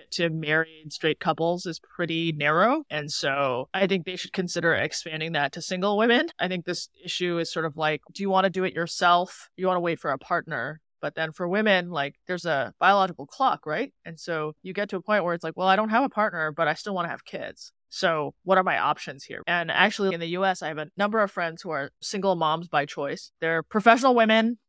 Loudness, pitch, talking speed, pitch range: -25 LUFS, 175 Hz, 245 wpm, 160-190 Hz